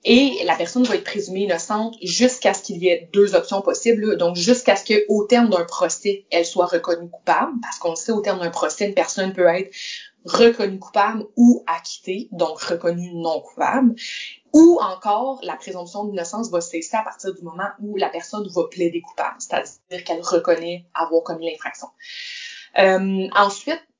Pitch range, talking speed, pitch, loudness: 175-220 Hz, 180 wpm, 195 Hz, -20 LUFS